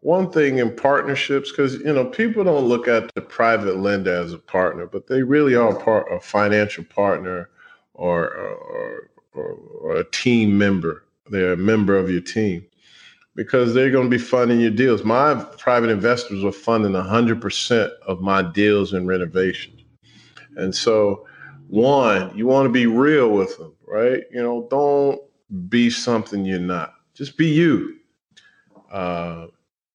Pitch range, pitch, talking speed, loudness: 100-140 Hz, 115 Hz, 160 wpm, -19 LUFS